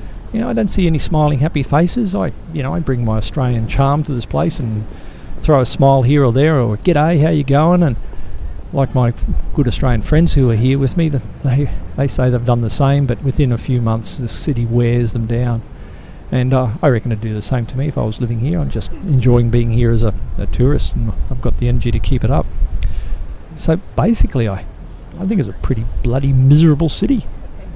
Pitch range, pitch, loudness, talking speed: 115-145 Hz, 125 Hz, -16 LUFS, 230 wpm